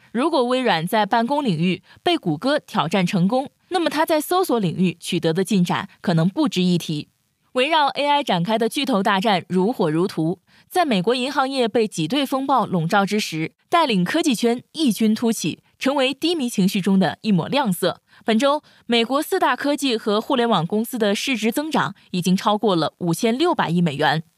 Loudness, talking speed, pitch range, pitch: -20 LUFS, 290 characters per minute, 185-270 Hz, 225 Hz